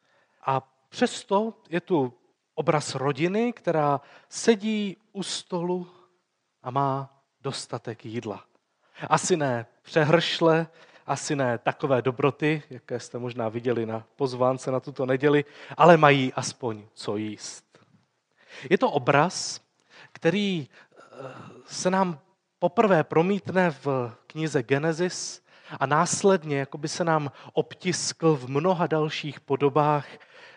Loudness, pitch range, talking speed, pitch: -25 LUFS, 130-175 Hz, 110 wpm, 150 Hz